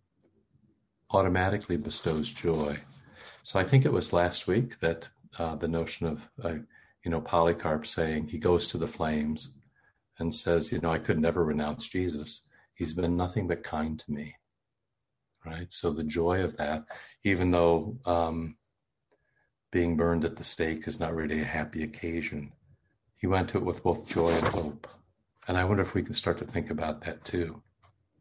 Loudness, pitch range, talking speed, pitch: -30 LUFS, 80-100 Hz, 175 wpm, 85 Hz